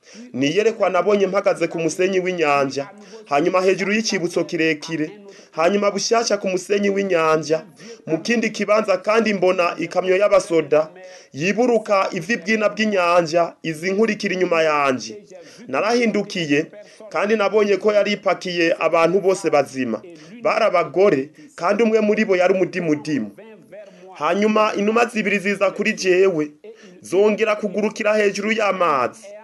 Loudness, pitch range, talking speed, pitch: -19 LUFS, 170-215 Hz, 115 wpm, 195 Hz